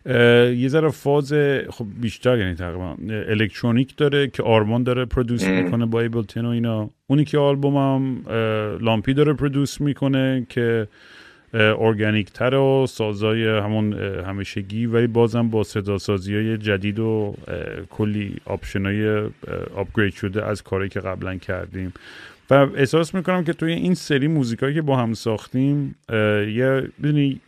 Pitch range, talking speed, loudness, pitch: 105-135 Hz, 140 wpm, -21 LUFS, 115 Hz